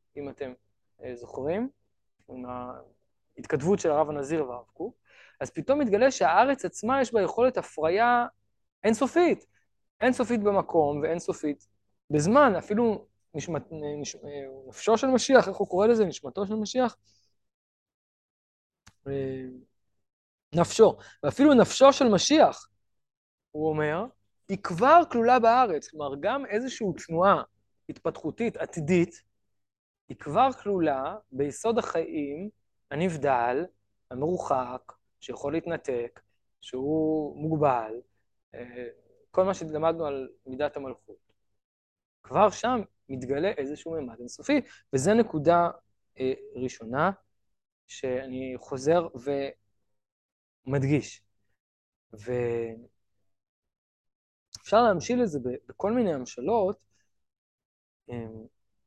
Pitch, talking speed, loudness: 150 Hz, 90 wpm, -26 LUFS